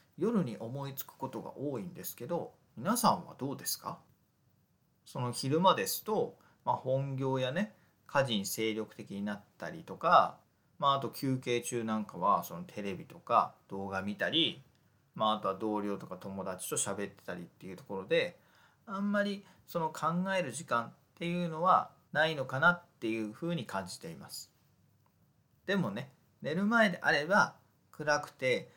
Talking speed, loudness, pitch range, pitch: 310 characters per minute, -33 LUFS, 110-175 Hz, 135 Hz